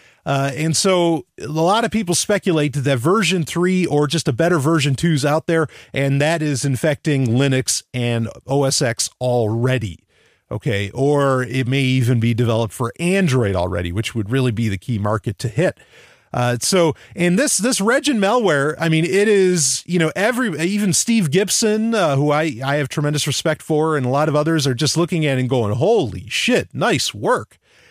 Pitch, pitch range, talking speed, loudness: 150 Hz, 130-175 Hz, 190 wpm, -18 LUFS